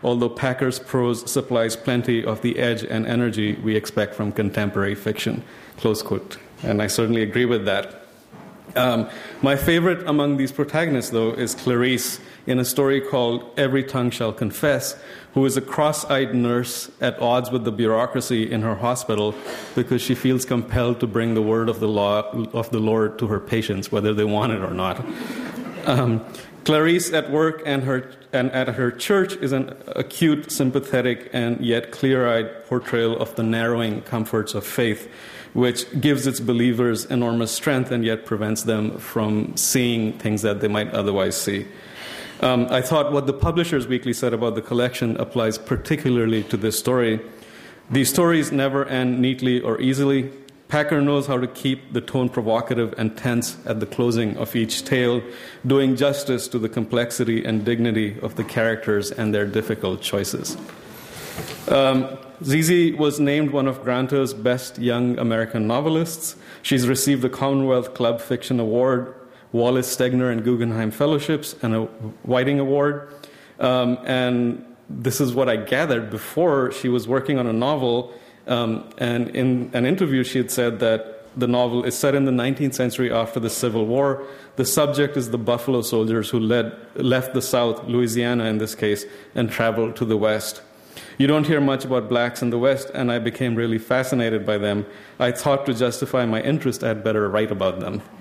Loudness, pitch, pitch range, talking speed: -22 LUFS, 125 Hz, 115-135 Hz, 175 wpm